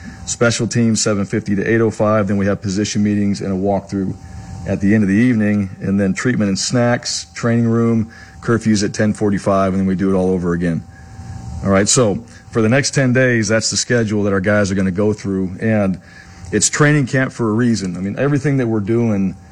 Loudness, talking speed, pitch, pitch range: -16 LUFS, 210 wpm, 105 Hz, 95-115 Hz